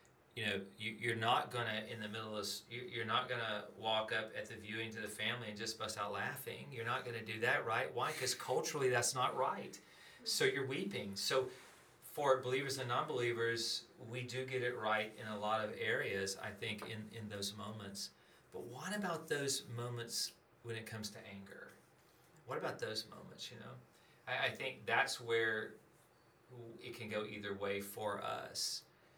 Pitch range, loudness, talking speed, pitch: 105-120 Hz, -40 LUFS, 185 wpm, 110 Hz